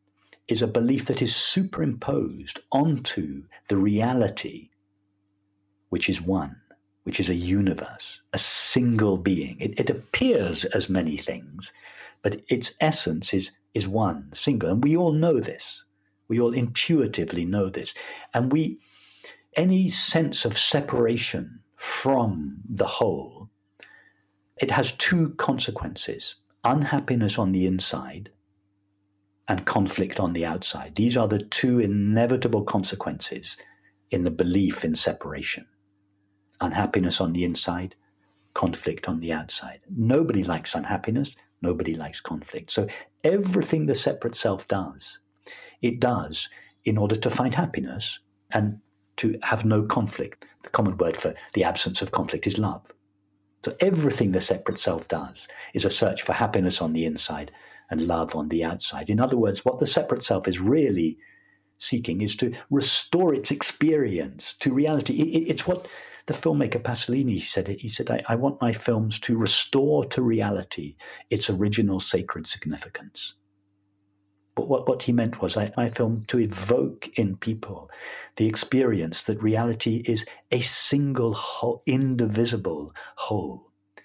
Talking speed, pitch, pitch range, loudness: 140 wpm, 110 Hz, 100-125 Hz, -25 LUFS